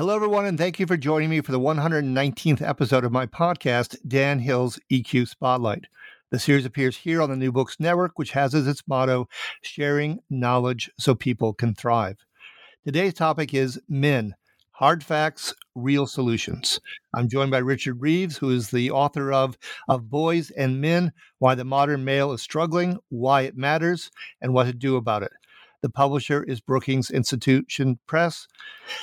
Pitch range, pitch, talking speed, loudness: 130-155 Hz, 135 Hz, 170 wpm, -23 LUFS